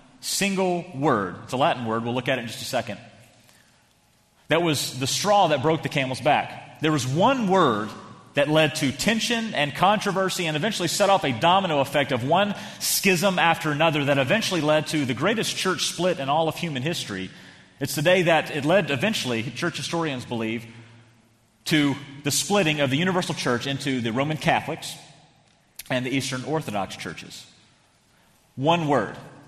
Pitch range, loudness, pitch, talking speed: 135-175 Hz, -23 LUFS, 150 Hz, 175 wpm